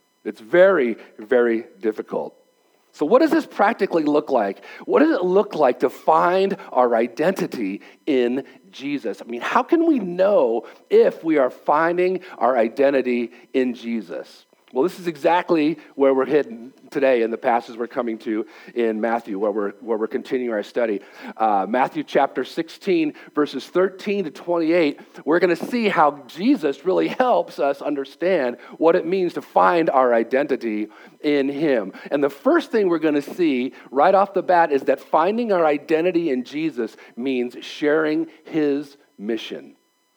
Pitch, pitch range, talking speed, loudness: 155 Hz, 130-190 Hz, 165 wpm, -21 LUFS